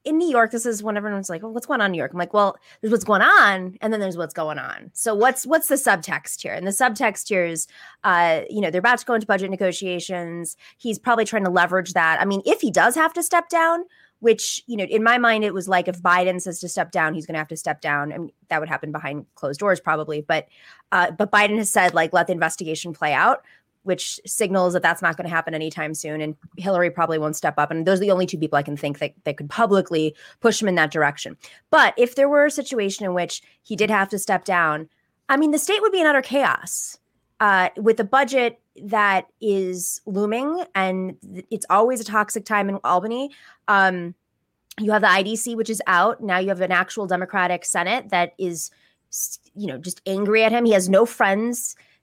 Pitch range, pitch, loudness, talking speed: 175-225 Hz, 195 Hz, -21 LUFS, 240 wpm